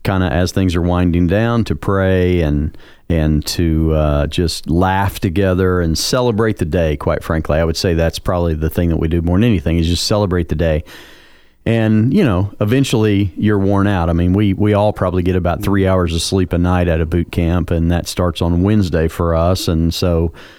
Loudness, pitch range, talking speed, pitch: -16 LUFS, 85-100 Hz, 215 wpm, 90 Hz